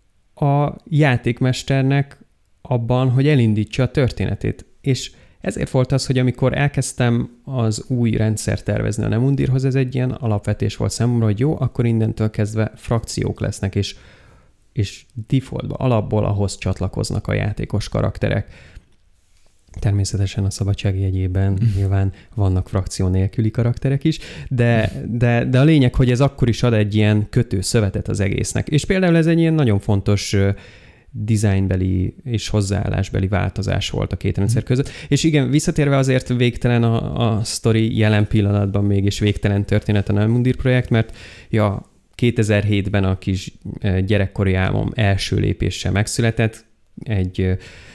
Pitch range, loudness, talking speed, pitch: 100-125 Hz, -19 LUFS, 140 wpm, 110 Hz